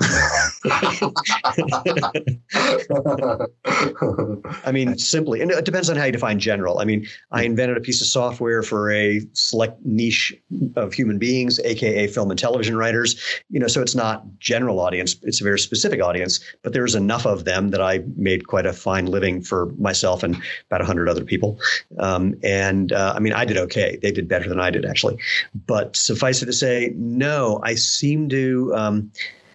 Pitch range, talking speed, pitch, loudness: 100-125 Hz, 175 wpm, 110 Hz, -20 LUFS